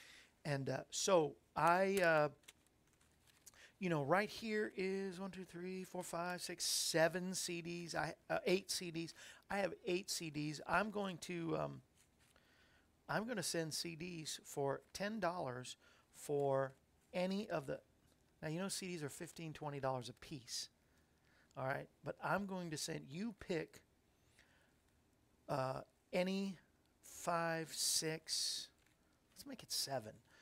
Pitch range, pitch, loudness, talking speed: 140-185 Hz, 170 Hz, -41 LUFS, 135 wpm